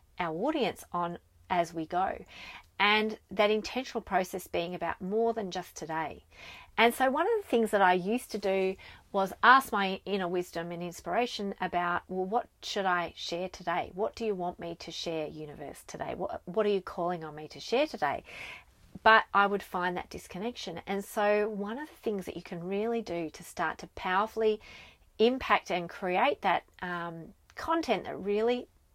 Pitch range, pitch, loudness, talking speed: 175-215 Hz, 195 Hz, -31 LUFS, 185 wpm